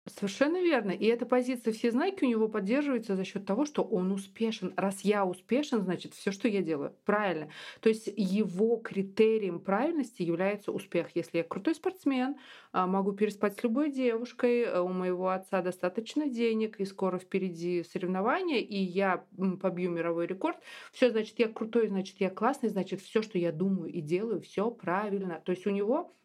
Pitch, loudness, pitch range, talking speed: 205 Hz, -31 LUFS, 185-235 Hz, 170 wpm